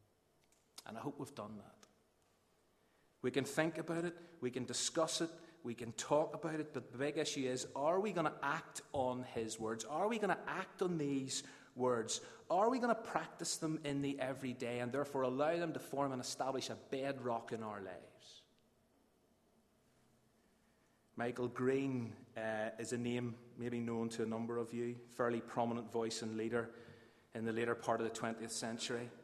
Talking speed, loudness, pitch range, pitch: 185 wpm, -40 LUFS, 115-140 Hz, 125 Hz